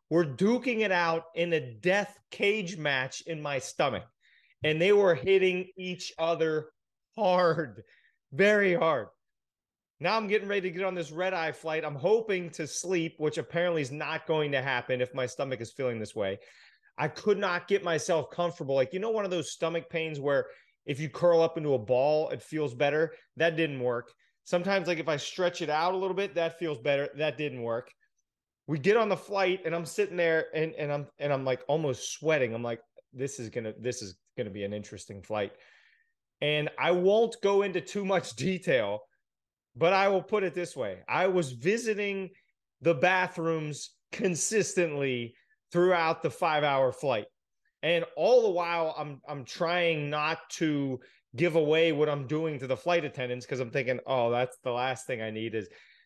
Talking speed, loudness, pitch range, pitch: 195 wpm, -29 LUFS, 140-180 Hz, 160 Hz